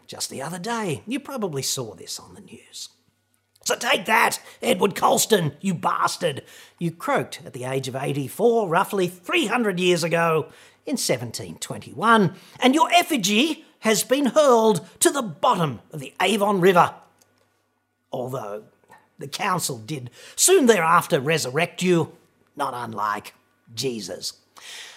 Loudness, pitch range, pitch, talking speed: -22 LUFS, 155-235 Hz, 185 Hz, 130 wpm